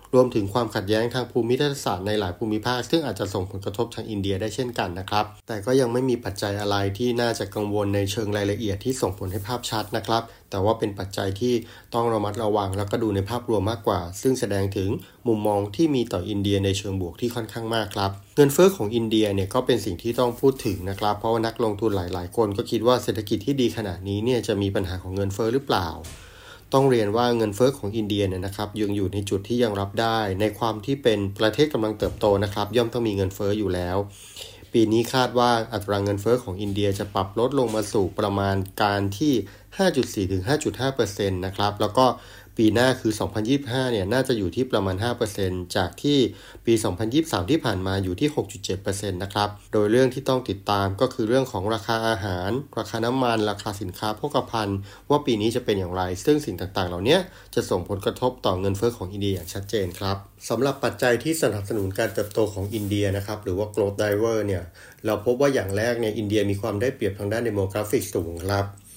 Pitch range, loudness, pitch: 100-120 Hz, -24 LUFS, 105 Hz